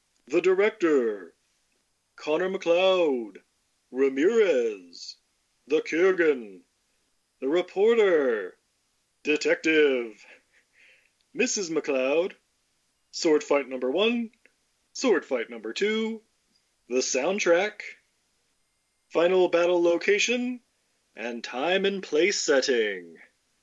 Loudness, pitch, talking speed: -25 LUFS, 200 Hz, 75 wpm